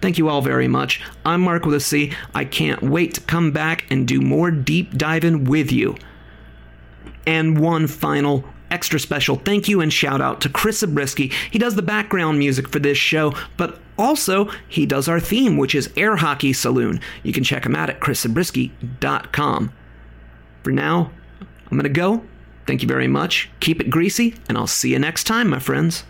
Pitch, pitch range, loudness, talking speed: 155 Hz, 135-175 Hz, -19 LUFS, 190 wpm